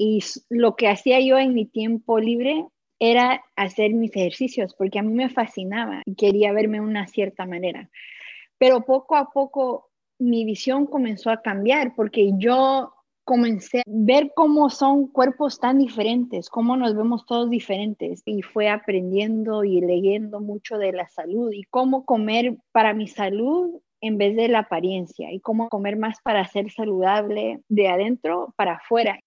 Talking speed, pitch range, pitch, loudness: 165 wpm, 205-255 Hz, 225 Hz, -21 LUFS